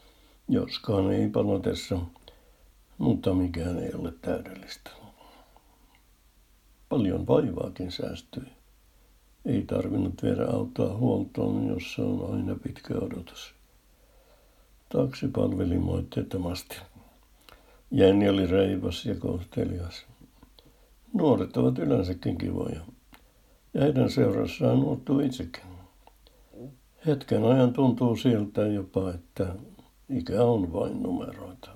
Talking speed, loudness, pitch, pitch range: 90 wpm, -27 LUFS, 95 Hz, 90-120 Hz